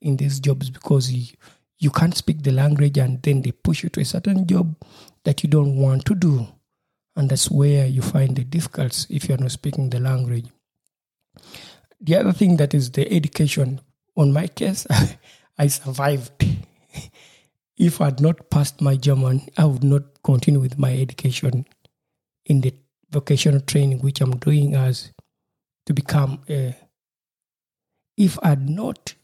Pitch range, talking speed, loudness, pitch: 135-155 Hz, 165 wpm, -20 LUFS, 140 Hz